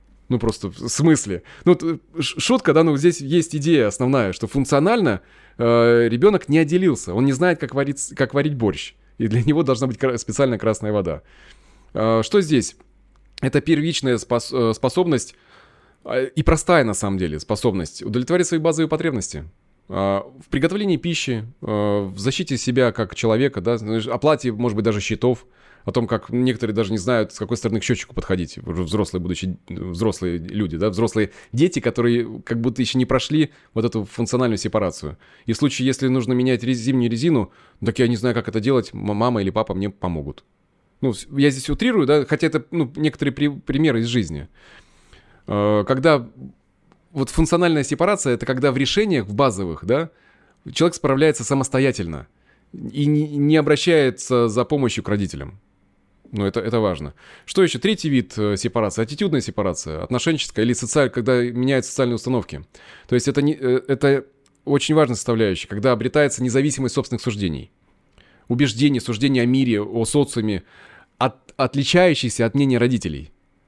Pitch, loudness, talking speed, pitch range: 125 Hz, -20 LUFS, 155 wpm, 110-145 Hz